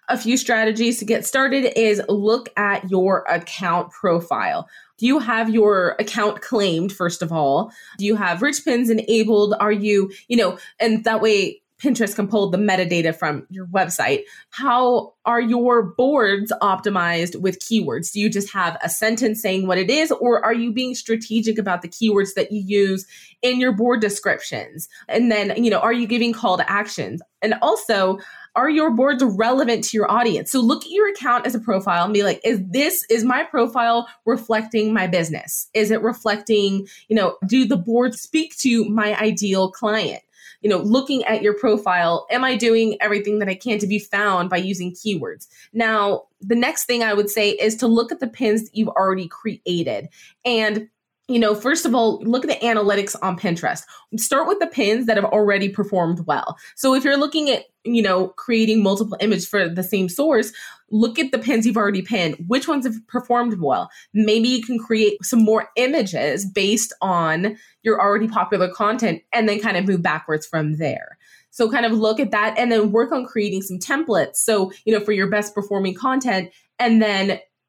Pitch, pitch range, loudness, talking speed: 220 Hz, 195-240 Hz, -19 LUFS, 195 wpm